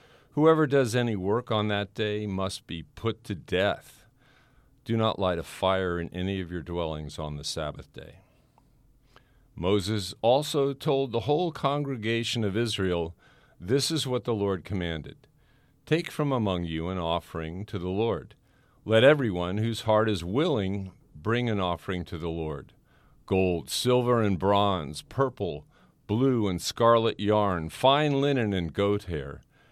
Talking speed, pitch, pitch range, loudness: 150 wpm, 105 Hz, 90-125 Hz, -27 LUFS